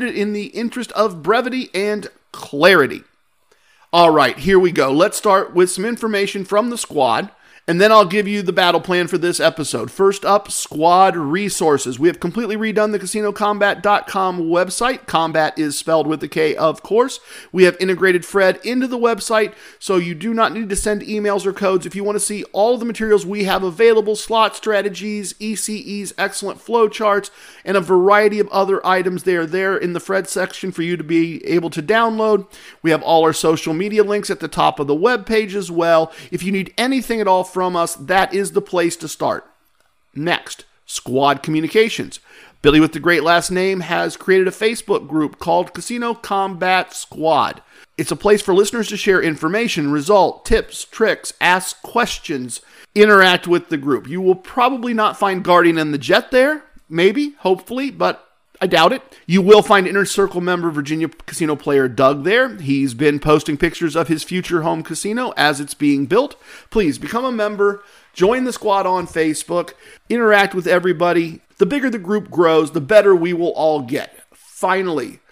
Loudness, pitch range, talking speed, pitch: -17 LUFS, 170-210 Hz, 185 wpm, 190 Hz